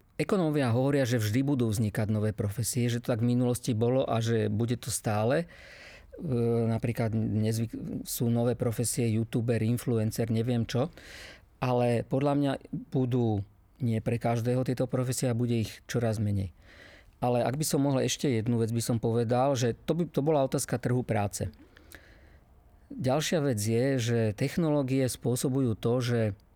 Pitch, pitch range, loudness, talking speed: 120 Hz, 110-130 Hz, -29 LUFS, 155 wpm